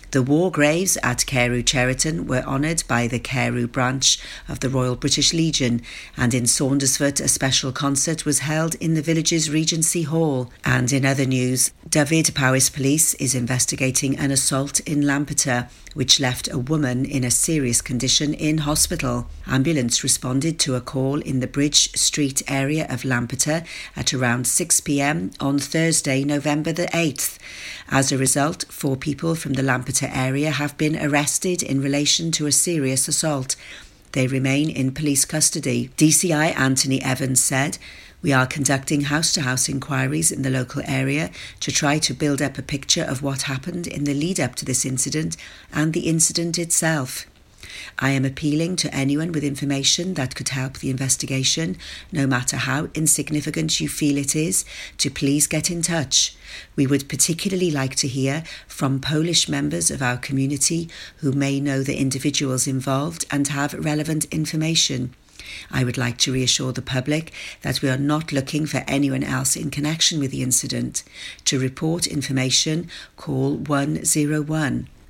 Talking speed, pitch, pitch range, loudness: 165 wpm, 140 Hz, 130-155 Hz, -20 LUFS